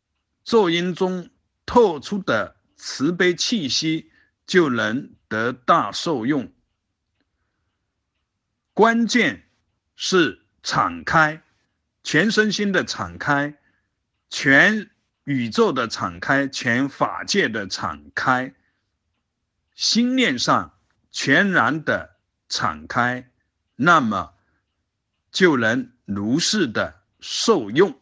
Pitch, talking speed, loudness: 135 Hz, 120 characters per minute, -20 LUFS